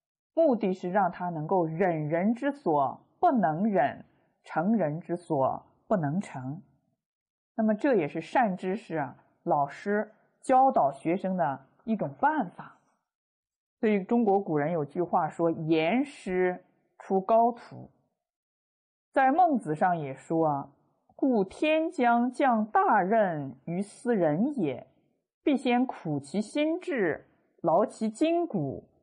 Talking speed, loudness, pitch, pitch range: 170 characters per minute, -28 LUFS, 200 Hz, 165-250 Hz